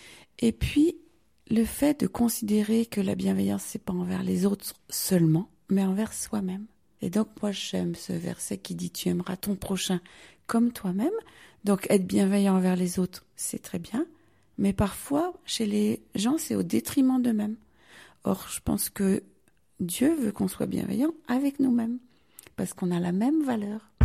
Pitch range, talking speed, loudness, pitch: 185-240 Hz, 170 wpm, -28 LUFS, 210 Hz